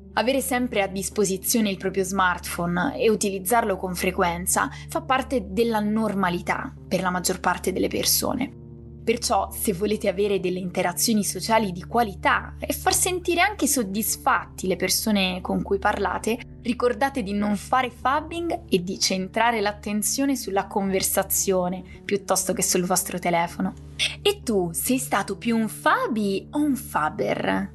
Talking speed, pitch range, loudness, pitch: 145 wpm, 185-235 Hz, -24 LUFS, 200 Hz